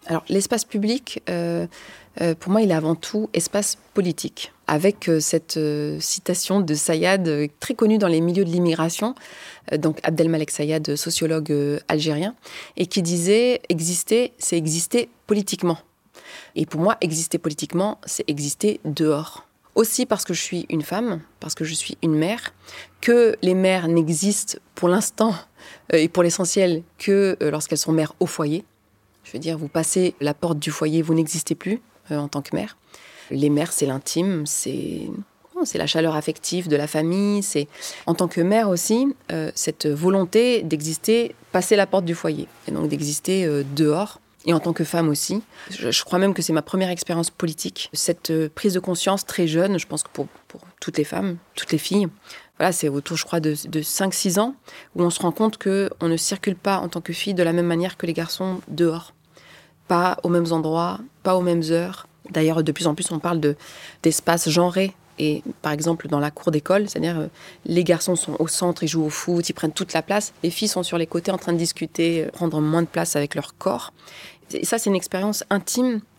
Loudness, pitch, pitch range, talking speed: -22 LUFS, 170 Hz, 160-190 Hz, 200 wpm